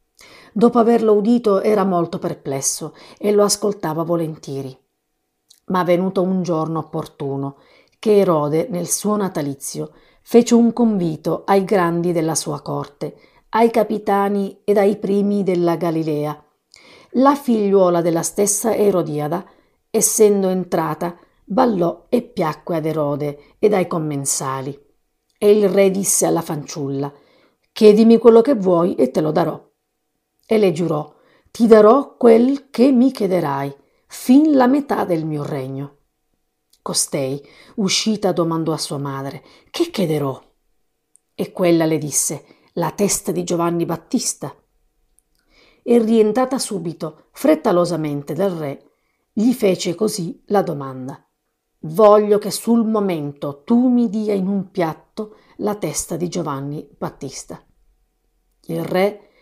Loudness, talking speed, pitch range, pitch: -18 LUFS, 125 wpm, 155-210 Hz, 180 Hz